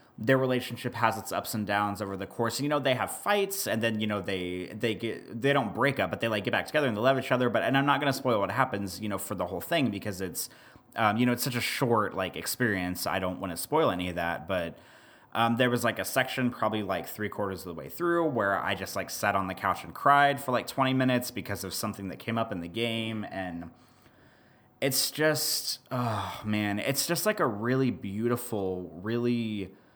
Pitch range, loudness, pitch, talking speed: 100-130 Hz, -29 LUFS, 115 Hz, 240 wpm